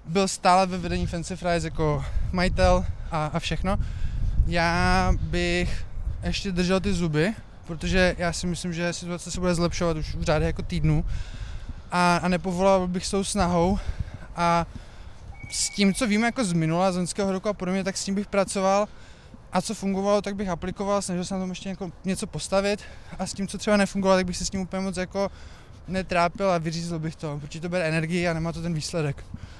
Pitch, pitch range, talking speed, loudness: 175 Hz, 155-190 Hz, 195 wpm, -26 LUFS